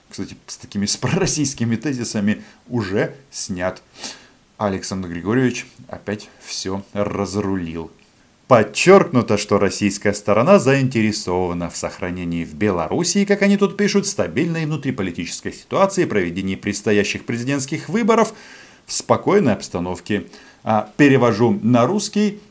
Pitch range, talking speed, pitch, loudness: 100-150 Hz, 100 wpm, 110 Hz, -19 LUFS